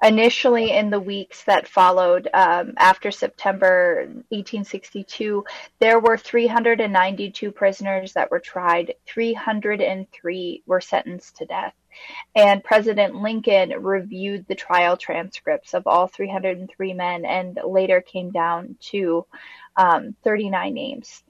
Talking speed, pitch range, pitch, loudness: 115 wpm, 185-225 Hz, 200 Hz, -20 LUFS